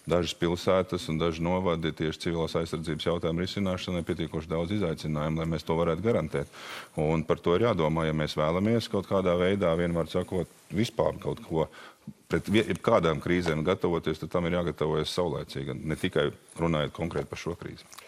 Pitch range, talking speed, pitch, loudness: 80-90 Hz, 165 wpm, 85 Hz, -29 LUFS